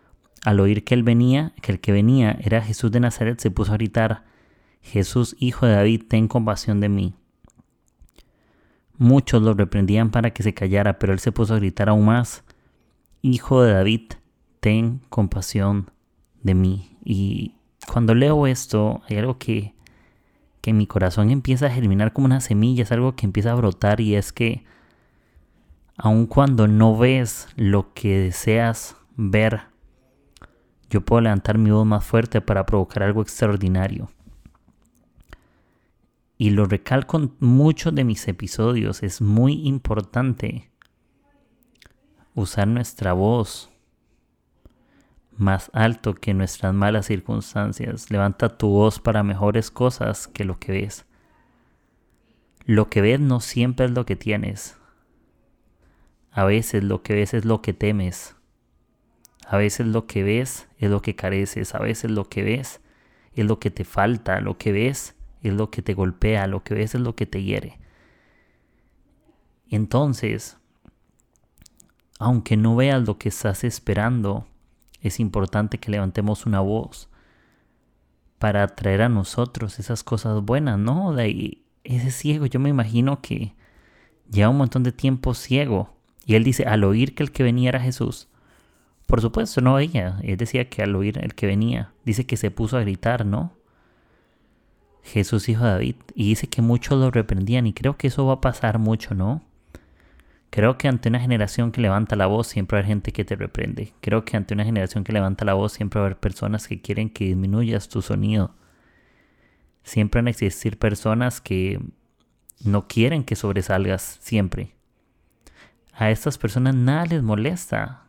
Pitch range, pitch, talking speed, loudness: 100-120 Hz, 110 Hz, 160 wpm, -21 LUFS